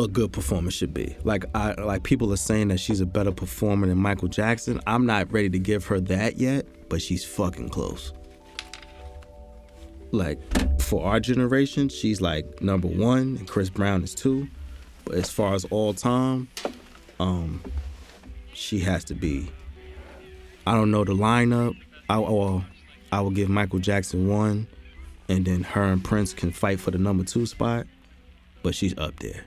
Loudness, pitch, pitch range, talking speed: -25 LUFS, 95 Hz, 85-105 Hz, 170 wpm